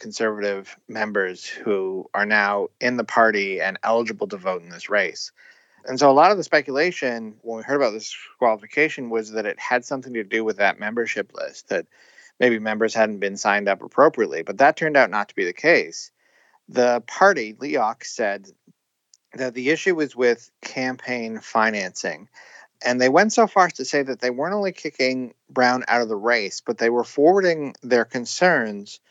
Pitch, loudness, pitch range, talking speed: 120 Hz, -21 LUFS, 110-130 Hz, 190 wpm